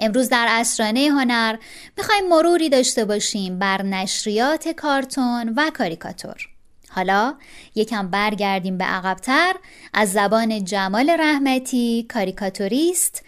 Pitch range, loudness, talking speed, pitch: 200-280 Hz, -19 LUFS, 105 wpm, 230 Hz